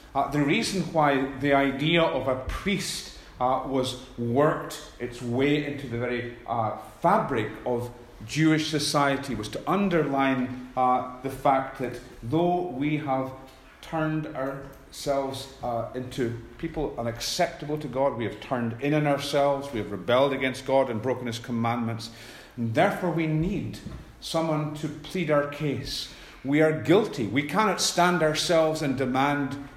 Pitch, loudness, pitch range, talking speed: 140 Hz, -26 LUFS, 125-155 Hz, 145 wpm